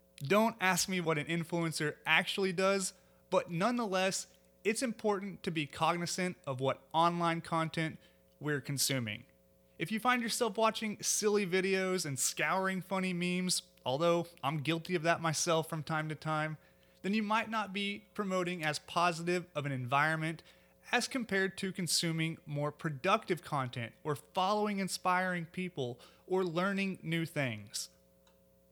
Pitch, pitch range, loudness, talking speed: 170 Hz, 150-190 Hz, -34 LUFS, 140 wpm